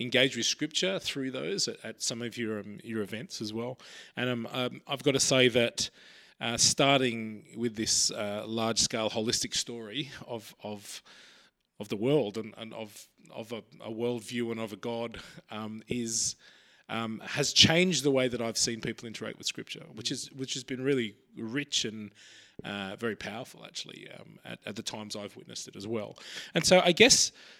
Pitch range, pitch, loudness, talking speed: 110-130 Hz, 115 Hz, -29 LUFS, 185 wpm